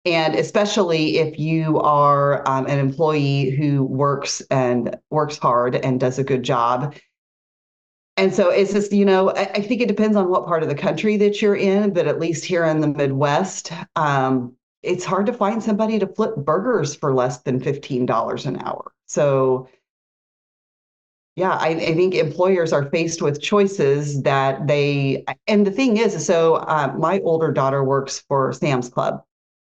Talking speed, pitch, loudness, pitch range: 170 wpm, 155 Hz, -19 LUFS, 135-190 Hz